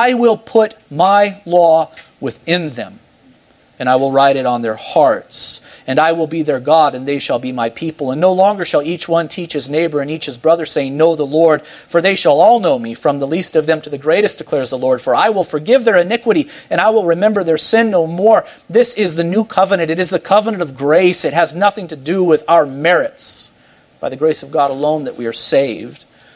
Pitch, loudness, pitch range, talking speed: 165 Hz, -14 LUFS, 145-185 Hz, 235 wpm